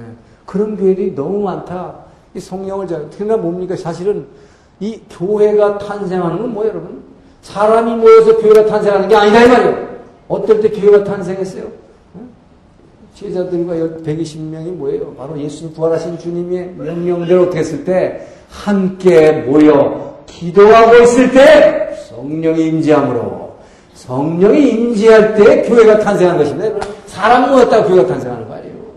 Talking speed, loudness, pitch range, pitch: 310 characters per minute, -11 LUFS, 165-215 Hz, 190 Hz